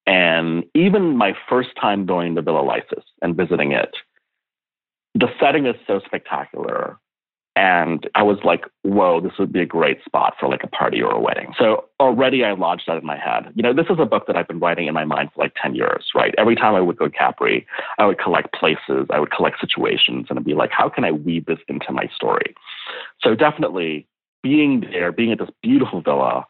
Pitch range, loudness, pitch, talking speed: 85-115 Hz, -19 LUFS, 85 Hz, 220 wpm